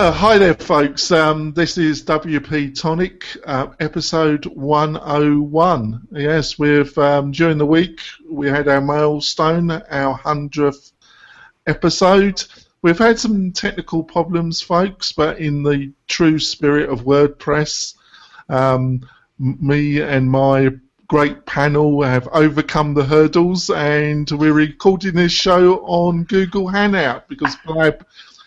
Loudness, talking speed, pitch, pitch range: -16 LUFS, 120 wpm, 155 Hz, 145-170 Hz